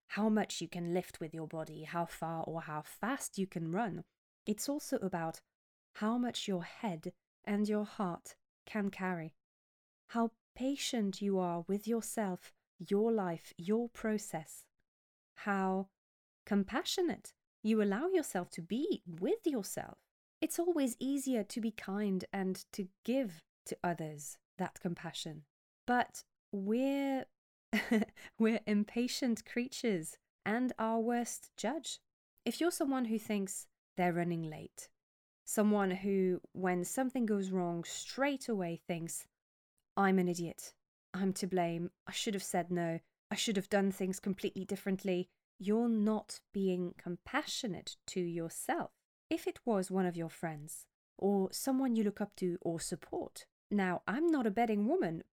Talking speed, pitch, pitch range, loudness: 140 wpm, 200 Hz, 175-230 Hz, -37 LUFS